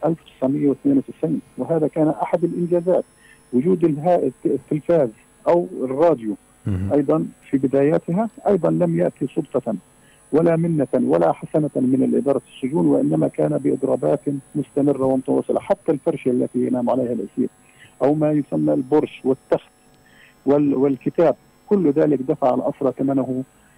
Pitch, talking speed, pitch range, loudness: 145 Hz, 115 wpm, 130-165 Hz, -20 LUFS